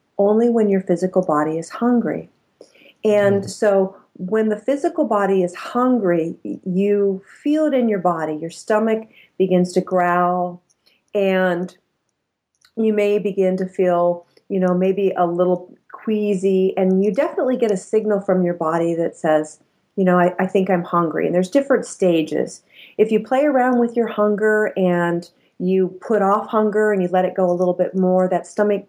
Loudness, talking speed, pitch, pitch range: -19 LUFS, 170 wpm, 190 Hz, 180-215 Hz